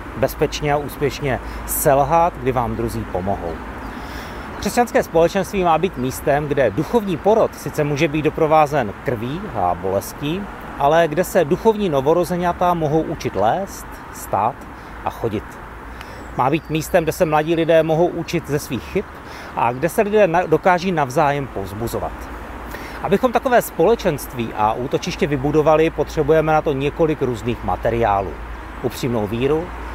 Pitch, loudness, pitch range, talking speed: 155 Hz, -19 LUFS, 120-175 Hz, 135 wpm